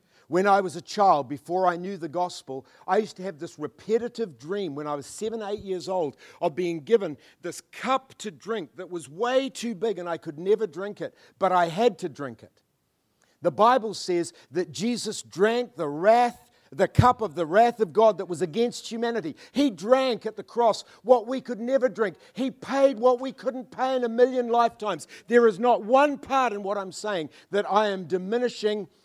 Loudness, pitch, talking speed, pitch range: -25 LUFS, 210 Hz, 205 wpm, 180-235 Hz